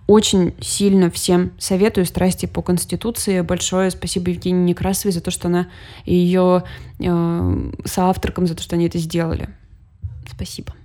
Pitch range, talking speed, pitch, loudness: 170-185 Hz, 140 wpm, 180 Hz, -18 LUFS